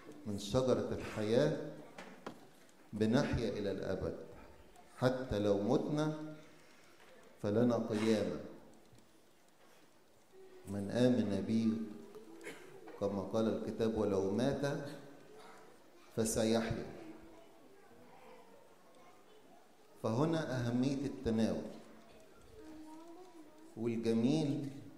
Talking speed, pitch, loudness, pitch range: 60 wpm, 115 Hz, -36 LUFS, 105-140 Hz